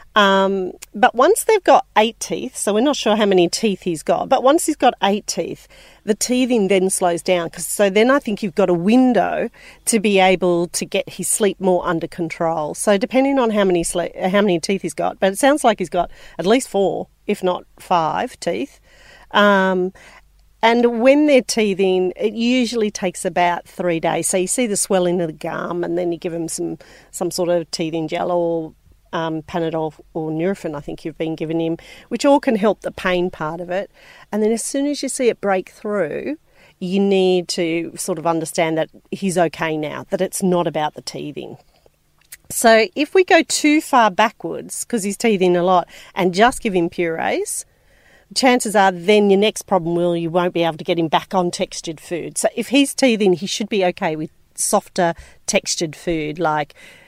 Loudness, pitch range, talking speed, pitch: -18 LUFS, 170-220 Hz, 205 wpm, 185 Hz